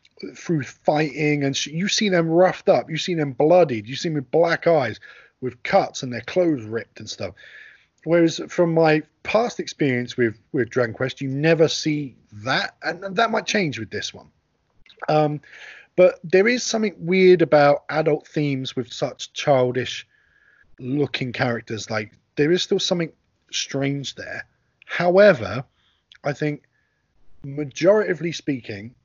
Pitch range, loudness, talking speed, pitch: 130-170 Hz, -21 LUFS, 150 wpm, 150 Hz